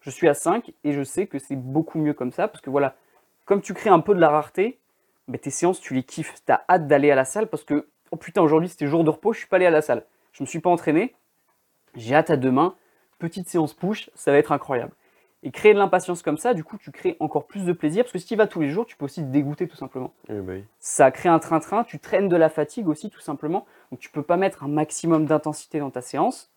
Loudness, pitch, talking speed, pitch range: -22 LUFS, 155 Hz, 280 wpm, 145-180 Hz